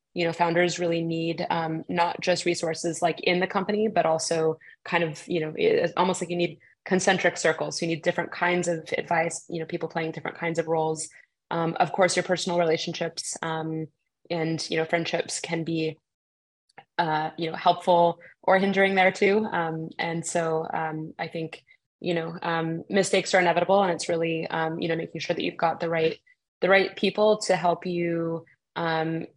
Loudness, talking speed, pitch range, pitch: -26 LUFS, 190 wpm, 160-175 Hz, 170 Hz